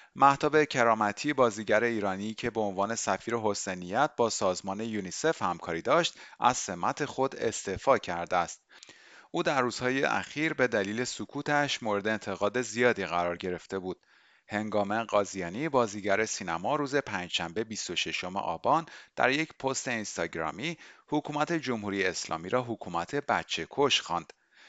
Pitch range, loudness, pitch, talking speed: 100-135 Hz, -30 LUFS, 110 Hz, 130 wpm